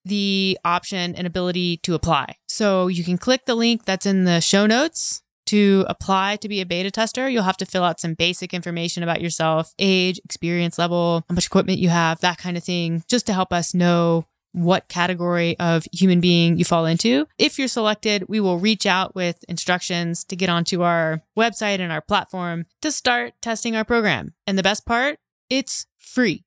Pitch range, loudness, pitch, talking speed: 170-205 Hz, -20 LUFS, 185 Hz, 195 wpm